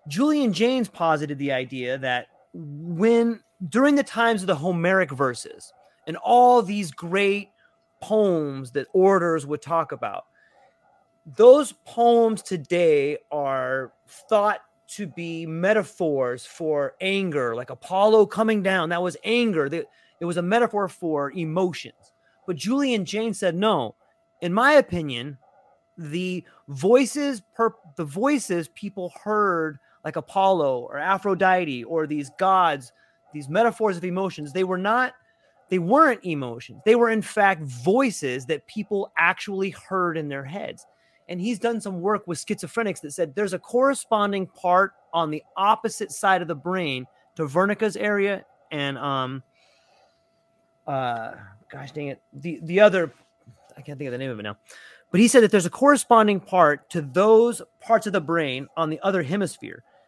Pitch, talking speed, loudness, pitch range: 185 Hz, 150 wpm, -22 LUFS, 155-215 Hz